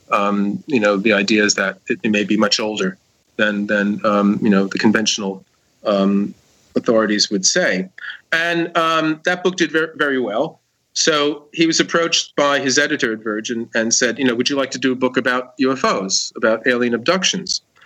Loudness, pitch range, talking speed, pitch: -17 LUFS, 105-145 Hz, 190 wpm, 120 Hz